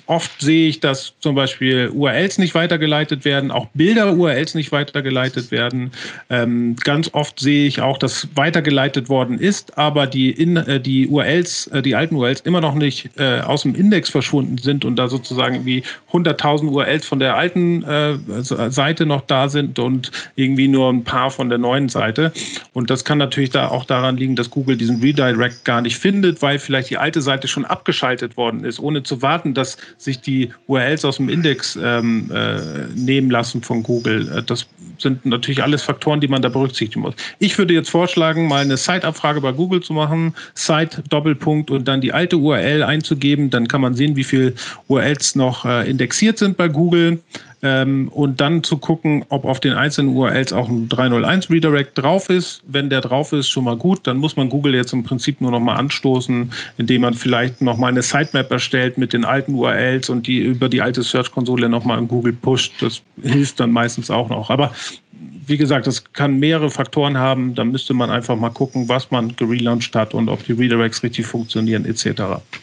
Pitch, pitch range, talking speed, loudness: 135 Hz, 125-150 Hz, 195 wpm, -17 LUFS